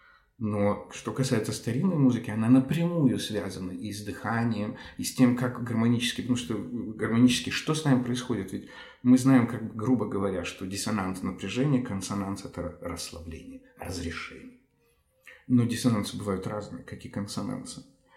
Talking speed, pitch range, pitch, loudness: 140 wpm, 100-125 Hz, 115 Hz, -28 LUFS